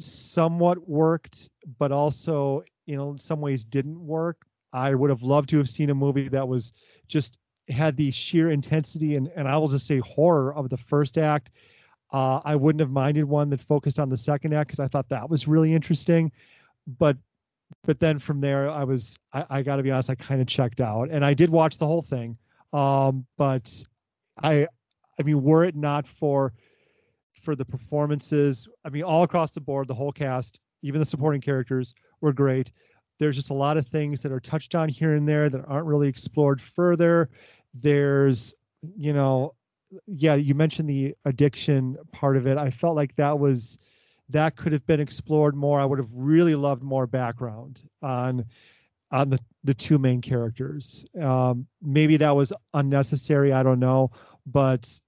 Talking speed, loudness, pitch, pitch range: 185 wpm, -24 LUFS, 140 Hz, 130-155 Hz